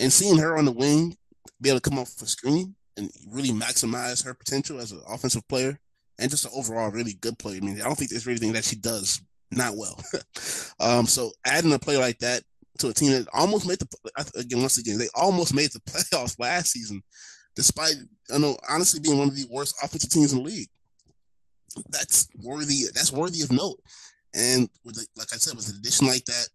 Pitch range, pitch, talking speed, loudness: 115-145 Hz, 125 Hz, 220 wpm, -24 LUFS